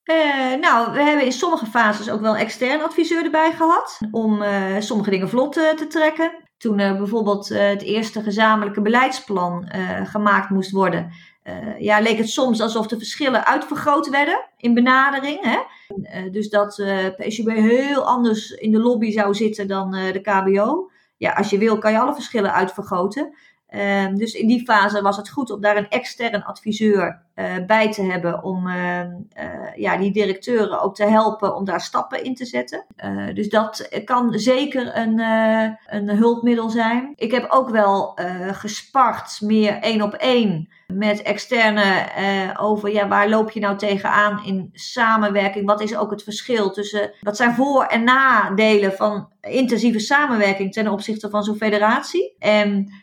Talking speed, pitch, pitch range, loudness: 175 wpm, 215 Hz, 200-240 Hz, -19 LUFS